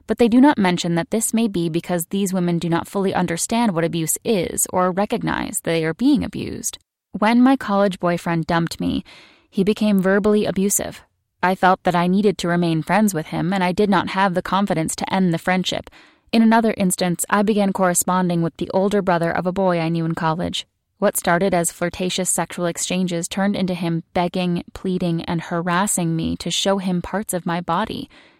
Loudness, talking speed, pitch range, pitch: -20 LUFS, 200 wpm, 170-205 Hz, 185 Hz